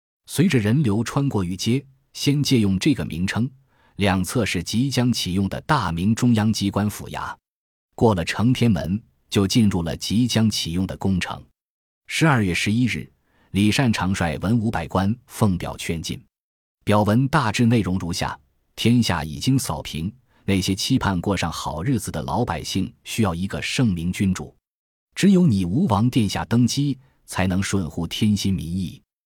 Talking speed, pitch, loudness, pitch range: 240 characters per minute, 100 Hz, -22 LUFS, 90-120 Hz